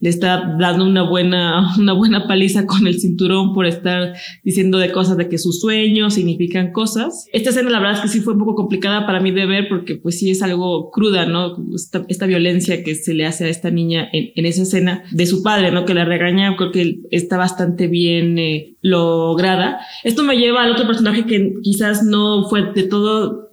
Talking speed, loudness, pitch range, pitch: 210 wpm, -16 LUFS, 175-205 Hz, 185 Hz